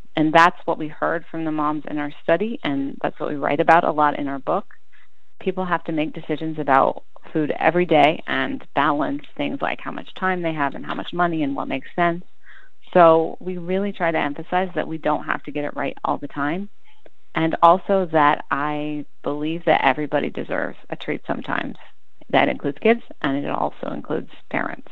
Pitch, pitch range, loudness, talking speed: 160 Hz, 150-180 Hz, -22 LUFS, 200 wpm